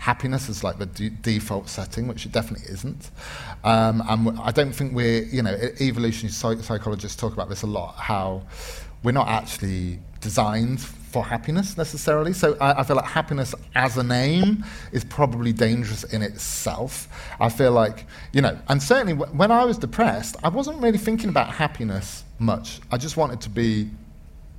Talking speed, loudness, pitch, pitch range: 180 wpm, -23 LUFS, 115 Hz, 105-135 Hz